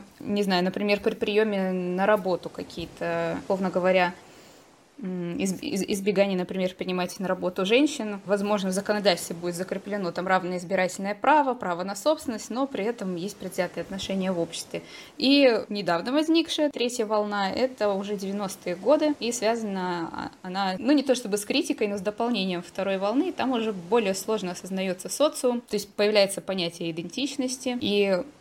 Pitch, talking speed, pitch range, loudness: 200 Hz, 150 wpm, 185-235 Hz, -26 LUFS